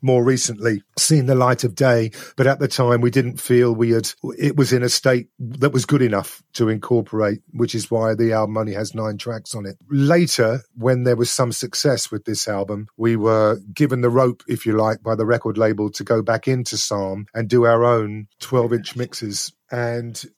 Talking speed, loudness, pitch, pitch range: 210 wpm, -19 LUFS, 120 Hz, 110-130 Hz